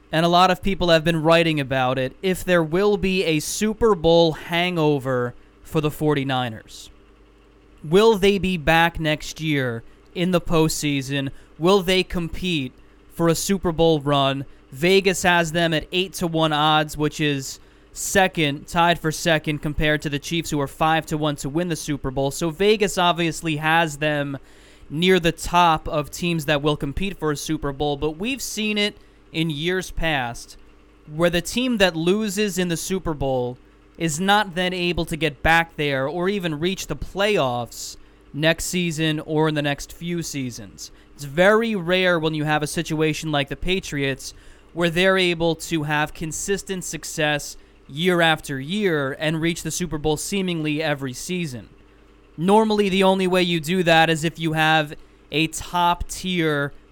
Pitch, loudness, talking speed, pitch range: 160 Hz, -21 LUFS, 170 wpm, 140-175 Hz